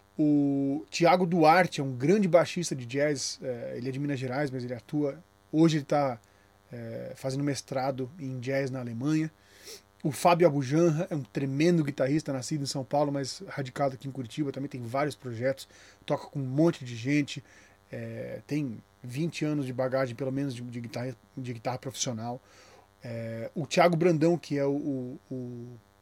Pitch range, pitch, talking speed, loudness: 125-150 Hz, 135 Hz, 175 wpm, -29 LUFS